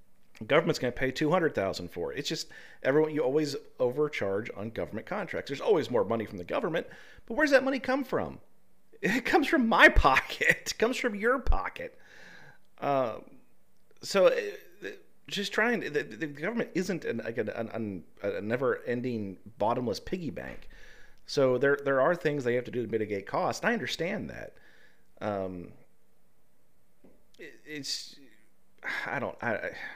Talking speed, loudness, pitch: 165 wpm, -29 LUFS, 160 Hz